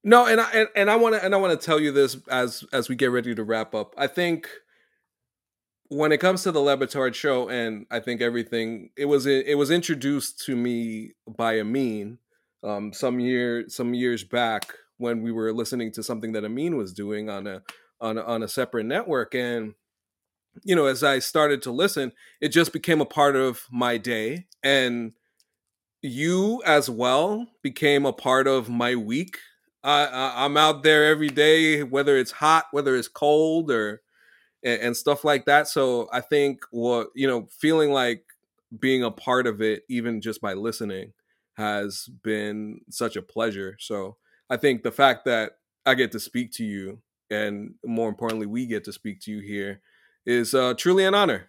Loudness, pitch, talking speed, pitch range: -23 LUFS, 125 Hz, 185 wpm, 115-145 Hz